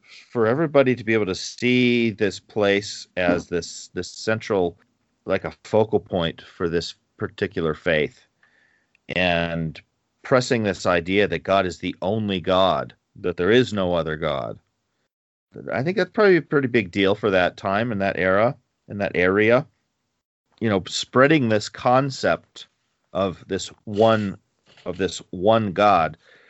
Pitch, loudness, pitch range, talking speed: 105 Hz, -22 LUFS, 95-120 Hz, 150 wpm